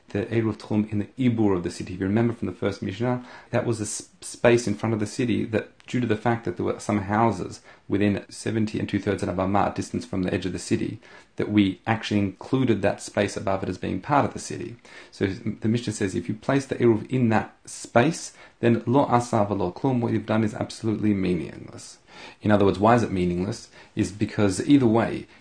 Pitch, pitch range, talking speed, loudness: 105 Hz, 100-115 Hz, 230 wpm, -25 LUFS